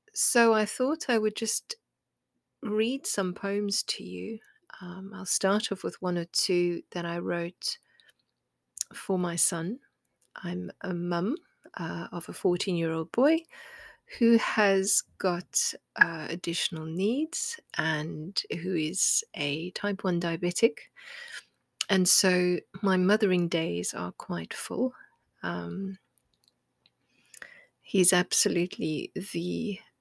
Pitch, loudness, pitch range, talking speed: 190 Hz, -28 LUFS, 175-220 Hz, 120 wpm